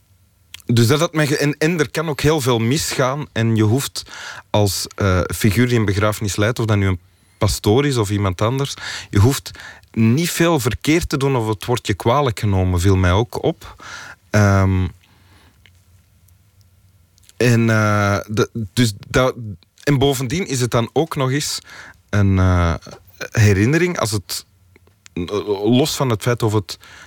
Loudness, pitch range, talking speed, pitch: -18 LUFS, 95-130 Hz, 160 wpm, 110 Hz